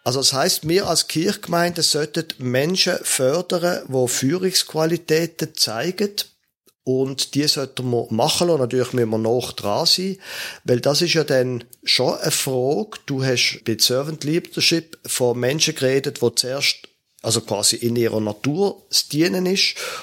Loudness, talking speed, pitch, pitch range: -20 LUFS, 150 wpm, 145 Hz, 125-170 Hz